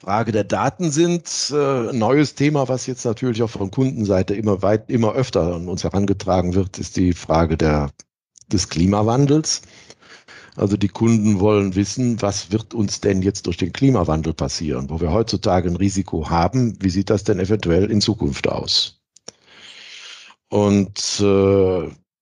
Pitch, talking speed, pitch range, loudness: 100 Hz, 155 wpm, 95-115 Hz, -19 LUFS